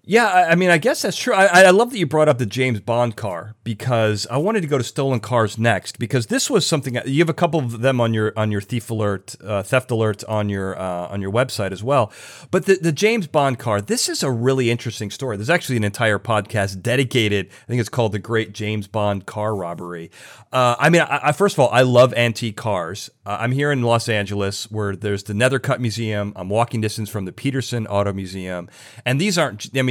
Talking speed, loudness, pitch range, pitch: 235 wpm, -19 LUFS, 105-135 Hz, 115 Hz